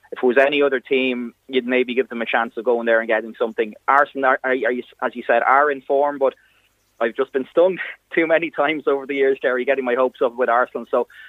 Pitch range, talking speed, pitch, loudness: 125-145 Hz, 250 wpm, 135 Hz, -20 LUFS